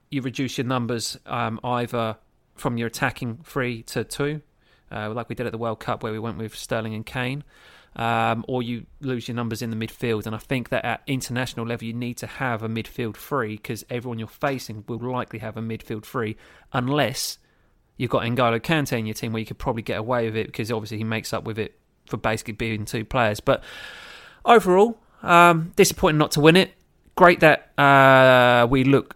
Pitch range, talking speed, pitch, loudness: 110-135 Hz, 210 wpm, 120 Hz, -22 LUFS